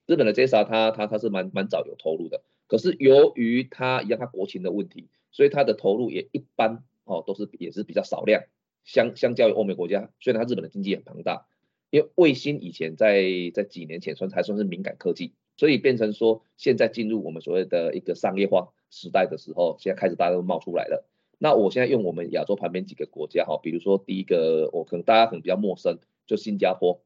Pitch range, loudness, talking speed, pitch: 95-130 Hz, -24 LUFS, 350 characters per minute, 110 Hz